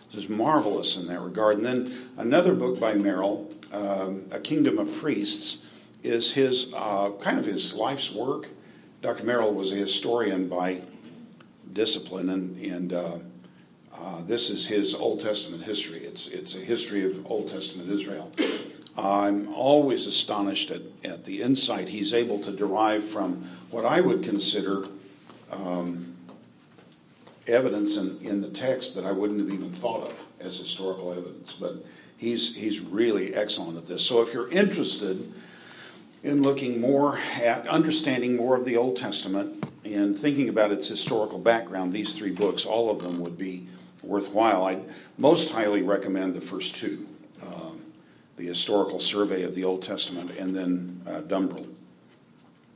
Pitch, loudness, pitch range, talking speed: 100 Hz, -27 LUFS, 90-115 Hz, 155 wpm